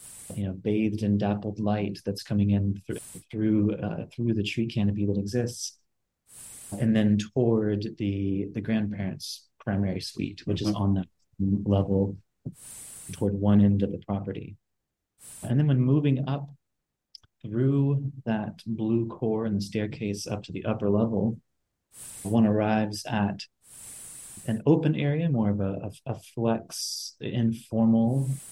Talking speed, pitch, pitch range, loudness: 140 wpm, 105 Hz, 100-115 Hz, -27 LUFS